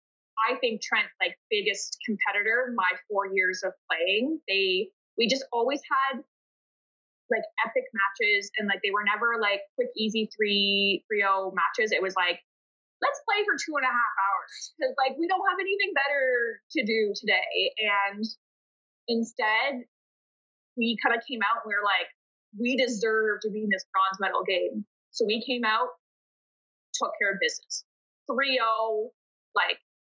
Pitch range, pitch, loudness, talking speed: 205-275 Hz, 230 Hz, -27 LUFS, 165 wpm